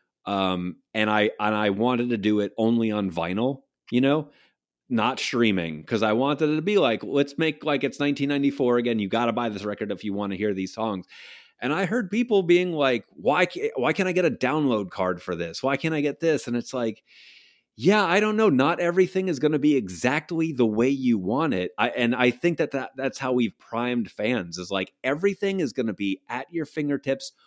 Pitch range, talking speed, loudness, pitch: 105-155 Hz, 225 wpm, -24 LUFS, 130 Hz